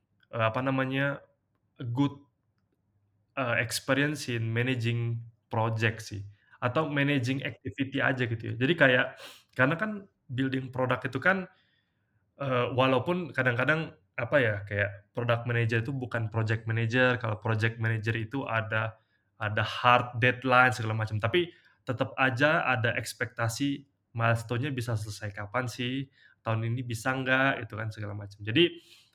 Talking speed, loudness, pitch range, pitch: 130 wpm, -29 LUFS, 110-135 Hz, 120 Hz